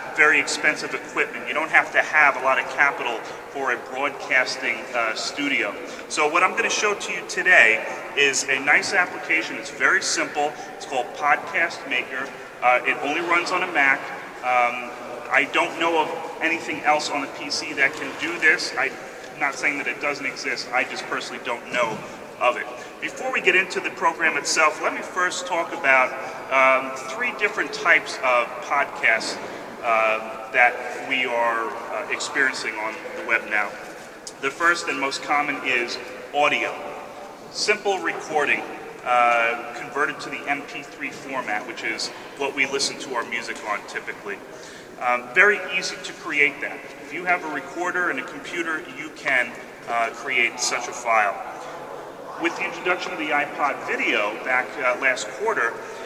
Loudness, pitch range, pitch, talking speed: -22 LUFS, 120-155 Hz, 130 Hz, 170 wpm